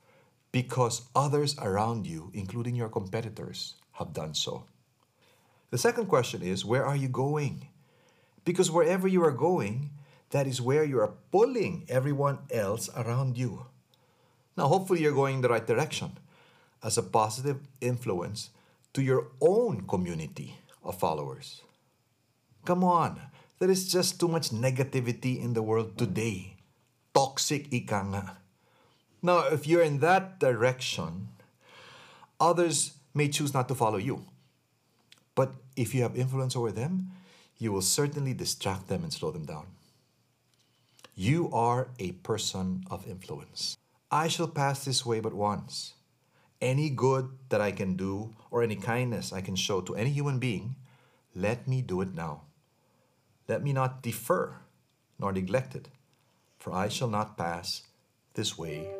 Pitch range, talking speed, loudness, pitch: 110-145 Hz, 145 wpm, -30 LUFS, 130 Hz